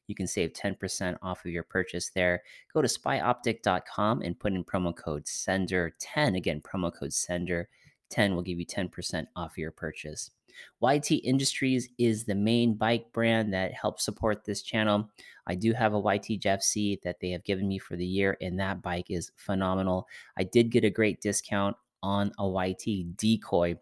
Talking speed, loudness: 180 wpm, -30 LUFS